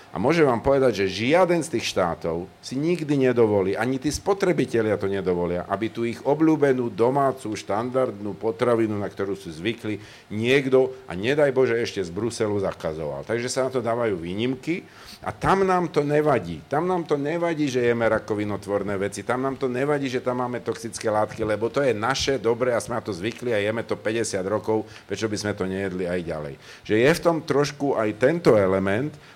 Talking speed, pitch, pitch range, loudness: 190 wpm, 115 Hz, 105-135 Hz, -24 LUFS